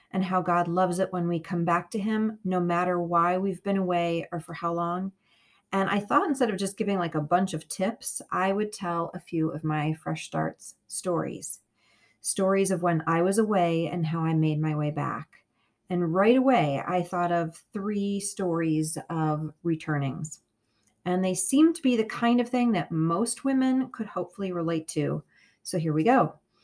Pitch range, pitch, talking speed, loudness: 160-195 Hz, 175 Hz, 195 wpm, -27 LUFS